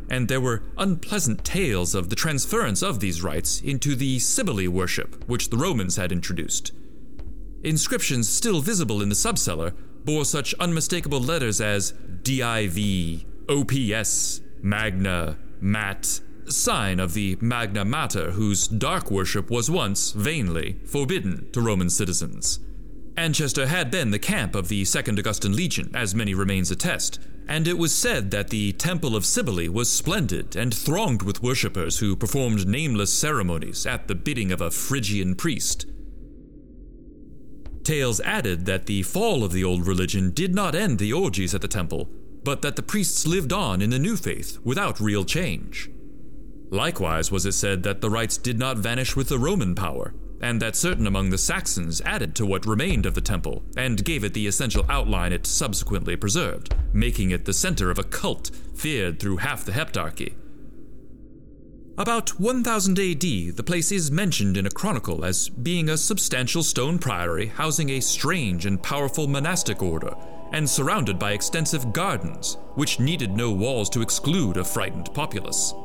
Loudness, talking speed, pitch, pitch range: -24 LUFS, 160 wpm, 110 Hz, 95-140 Hz